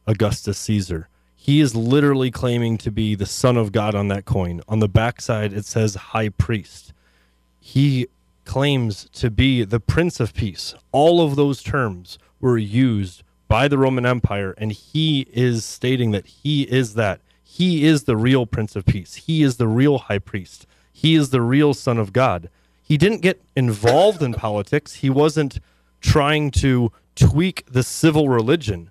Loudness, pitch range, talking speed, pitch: -19 LUFS, 105-140 Hz, 170 wpm, 120 Hz